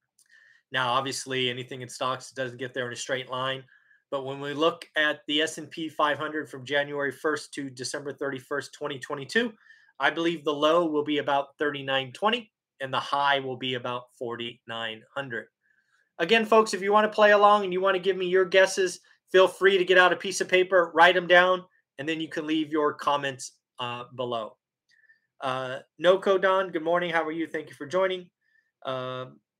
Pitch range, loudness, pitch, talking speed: 130-185 Hz, -26 LUFS, 150 Hz, 190 wpm